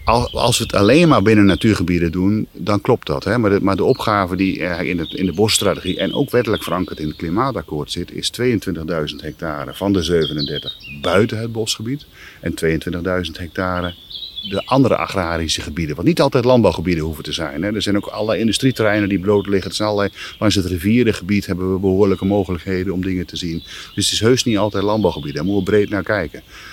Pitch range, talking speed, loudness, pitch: 90-105 Hz, 200 wpm, -18 LUFS, 95 Hz